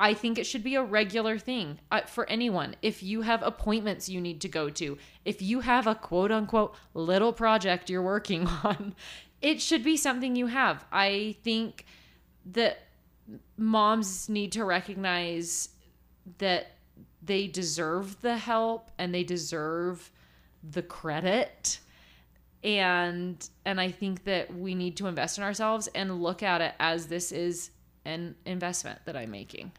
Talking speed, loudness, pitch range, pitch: 155 wpm, -29 LUFS, 170-220 Hz, 190 Hz